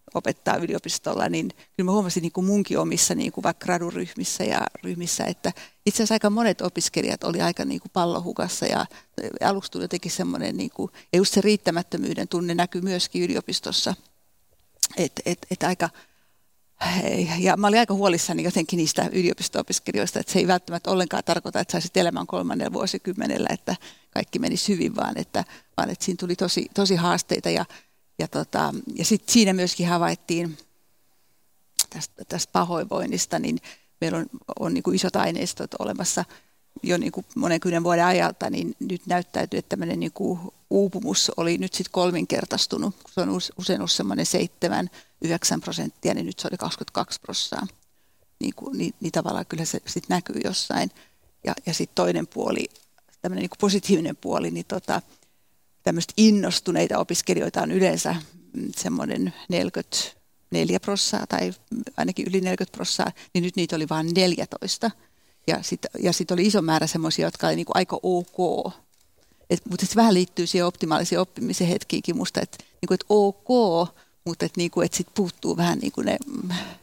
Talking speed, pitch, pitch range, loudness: 160 wpm, 180 Hz, 175-195 Hz, -24 LUFS